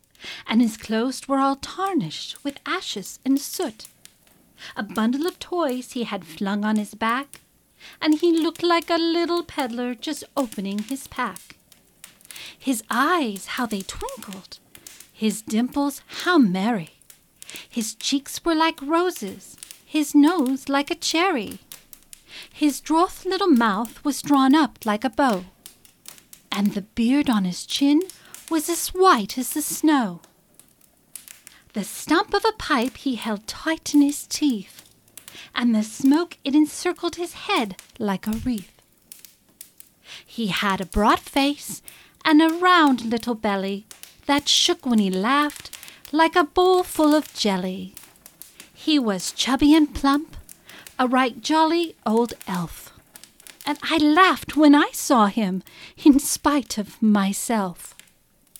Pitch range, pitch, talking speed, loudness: 220-315 Hz, 275 Hz, 140 wpm, -22 LUFS